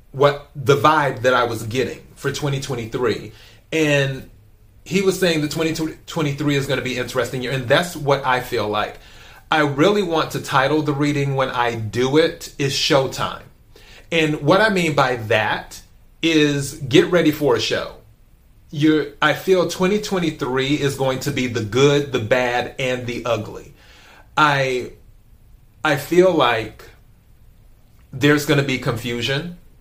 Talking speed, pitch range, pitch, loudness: 150 wpm, 125-155 Hz, 140 Hz, -19 LUFS